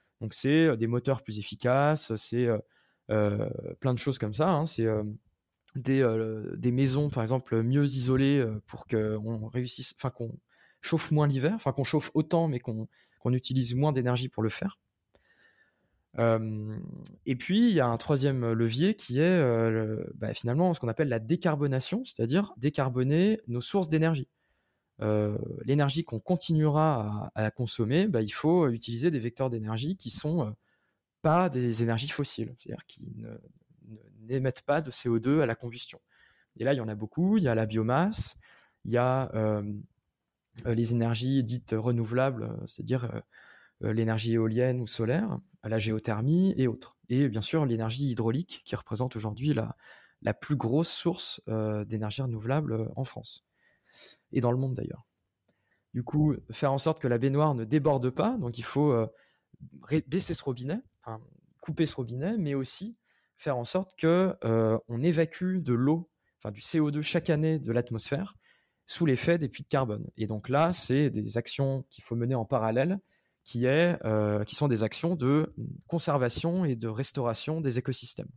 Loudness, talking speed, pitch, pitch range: -27 LUFS, 170 wpm, 130 Hz, 115-155 Hz